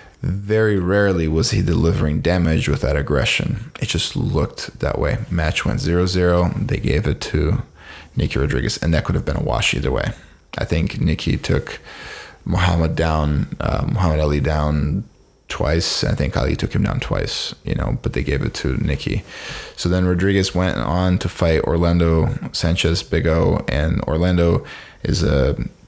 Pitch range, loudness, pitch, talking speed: 80-90 Hz, -19 LUFS, 85 Hz, 170 wpm